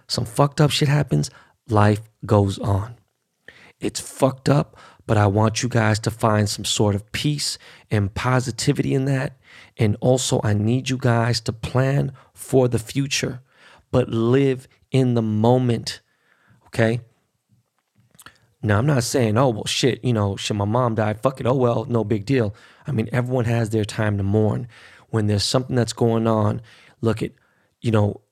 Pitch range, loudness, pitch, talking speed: 105-130 Hz, -21 LUFS, 115 Hz, 170 wpm